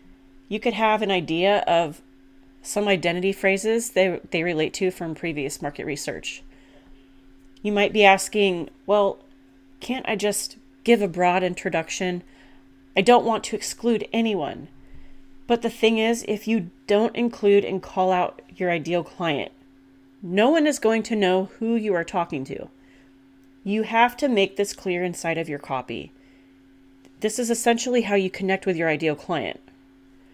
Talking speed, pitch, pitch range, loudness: 160 wpm, 185 Hz, 135-215 Hz, -23 LUFS